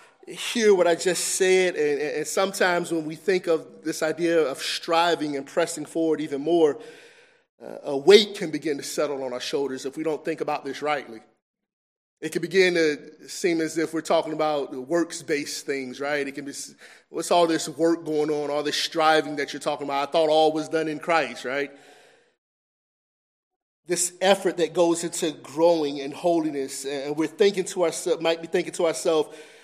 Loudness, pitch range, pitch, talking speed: -24 LUFS, 150-170 Hz, 160 Hz, 190 wpm